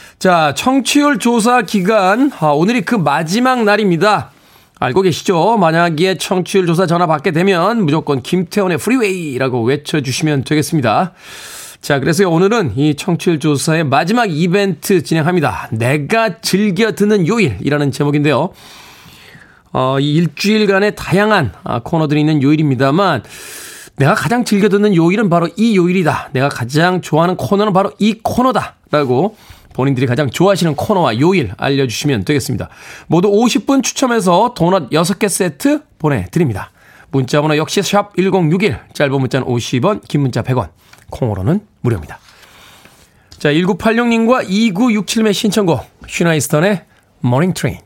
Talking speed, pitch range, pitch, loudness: 310 characters per minute, 145-210 Hz, 175 Hz, -14 LUFS